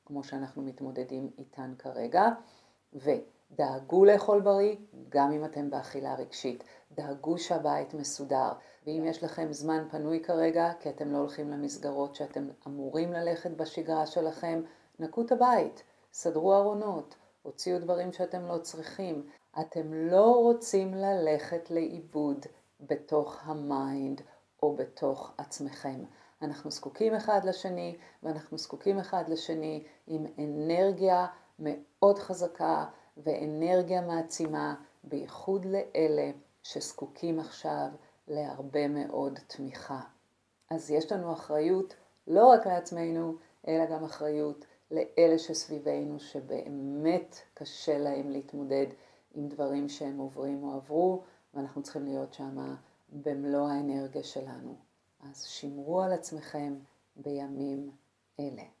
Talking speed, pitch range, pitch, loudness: 110 wpm, 140-170 Hz, 155 Hz, -31 LUFS